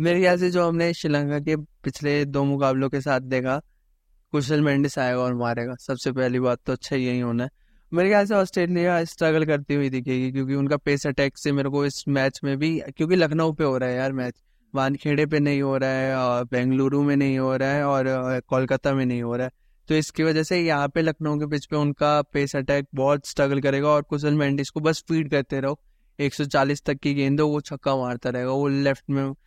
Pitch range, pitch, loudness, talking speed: 135-150 Hz, 140 Hz, -23 LUFS, 155 wpm